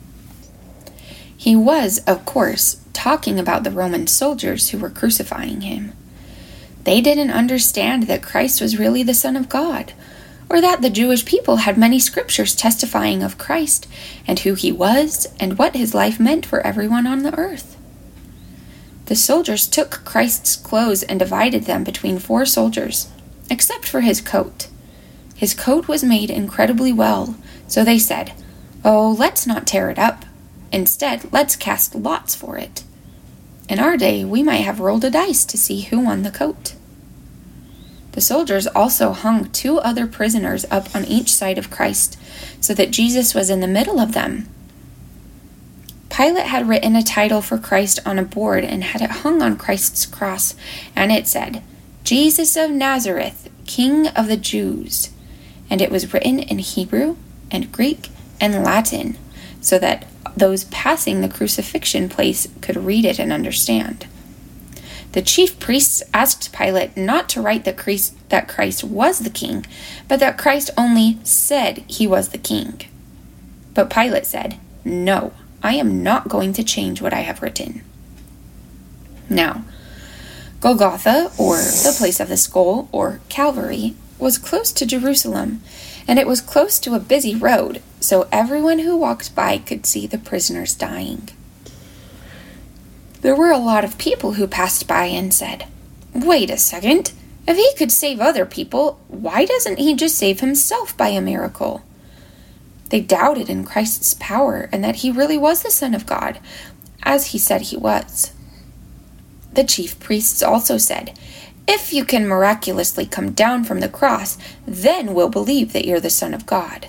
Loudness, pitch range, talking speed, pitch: -17 LUFS, 200-285 Hz, 160 wpm, 235 Hz